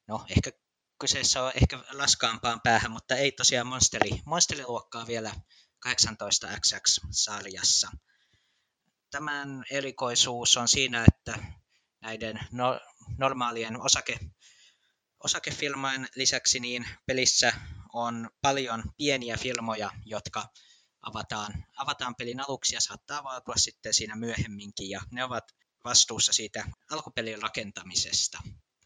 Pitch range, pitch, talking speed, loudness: 110-130 Hz, 120 Hz, 100 wpm, -27 LUFS